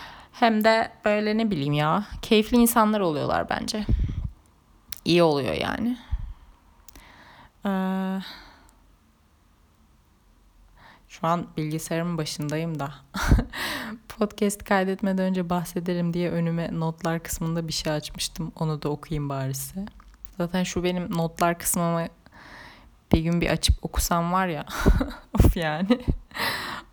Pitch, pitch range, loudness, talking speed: 170 Hz, 150-190 Hz, -25 LUFS, 110 wpm